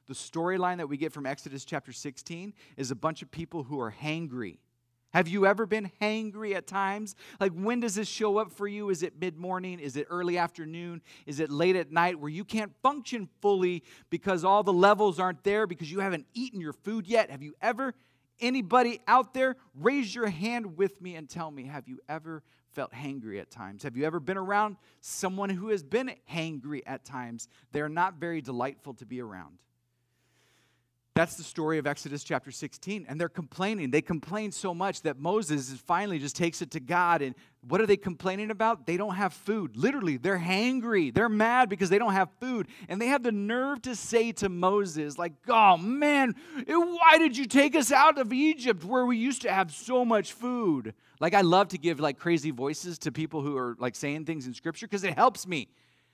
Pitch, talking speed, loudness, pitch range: 180 Hz, 210 wpm, -28 LUFS, 150-215 Hz